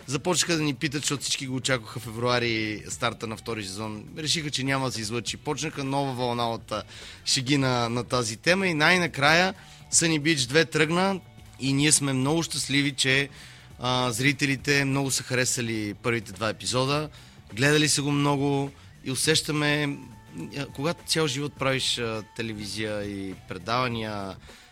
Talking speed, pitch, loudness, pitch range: 150 wpm, 130 Hz, -25 LUFS, 115-145 Hz